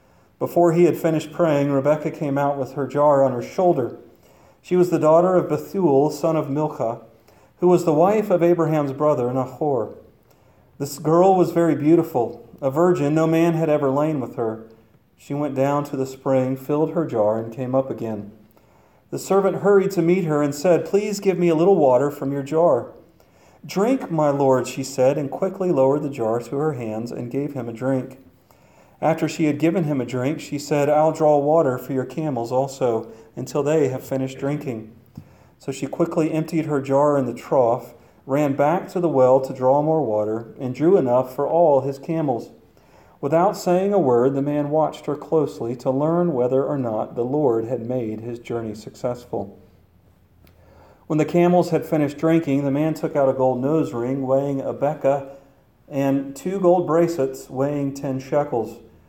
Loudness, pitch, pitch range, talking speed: -21 LUFS, 140 Hz, 130-160 Hz, 185 wpm